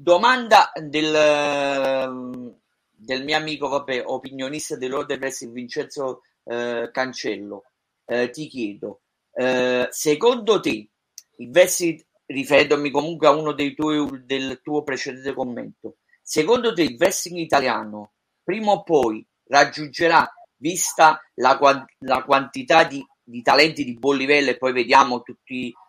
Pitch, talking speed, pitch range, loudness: 140 Hz, 120 wpm, 125-155 Hz, -20 LUFS